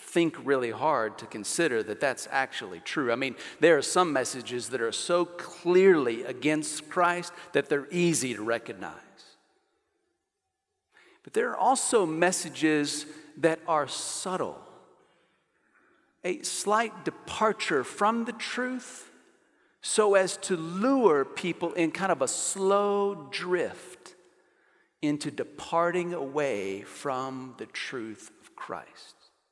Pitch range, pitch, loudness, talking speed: 150-220 Hz, 175 Hz, -28 LUFS, 120 wpm